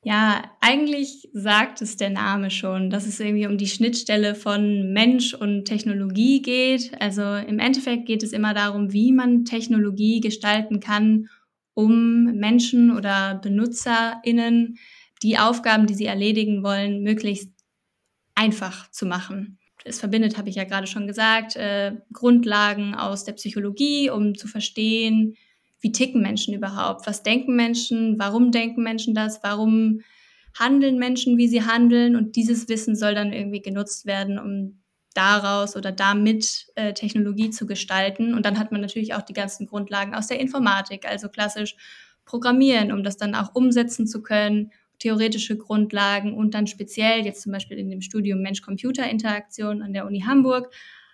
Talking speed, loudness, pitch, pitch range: 155 wpm, -22 LUFS, 215 Hz, 205-230 Hz